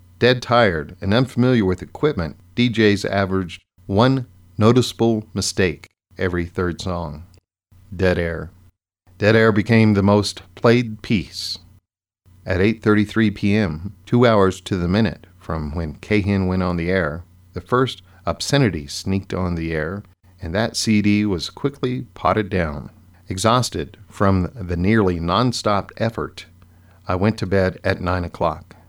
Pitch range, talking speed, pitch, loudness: 90-110 Hz, 135 wpm, 95 Hz, -20 LUFS